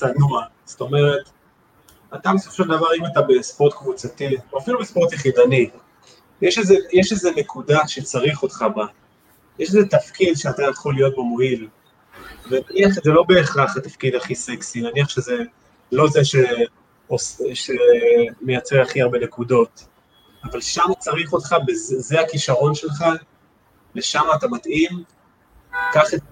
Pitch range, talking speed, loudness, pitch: 130-190 Hz, 130 wpm, -19 LUFS, 155 Hz